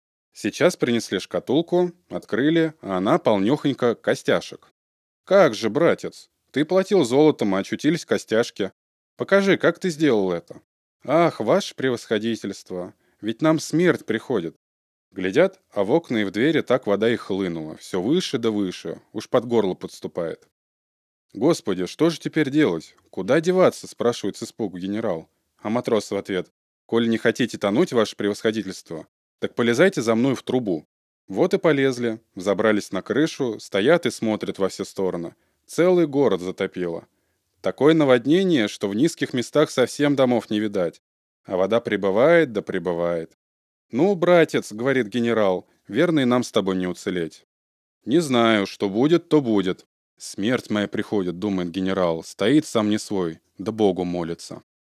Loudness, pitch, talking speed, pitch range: -22 LUFS, 110 Hz, 145 wpm, 95-140 Hz